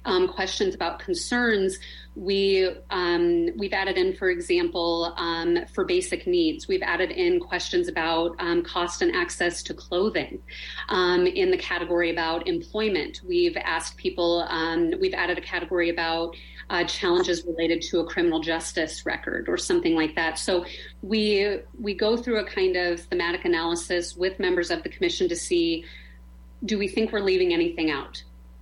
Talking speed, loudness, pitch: 160 wpm, -25 LUFS, 185 Hz